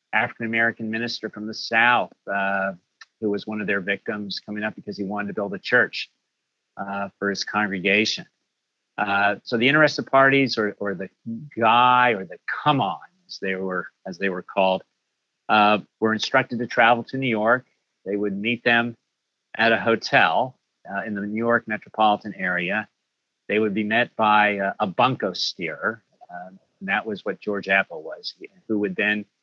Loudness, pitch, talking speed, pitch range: -22 LUFS, 105 Hz, 175 wpm, 100-115 Hz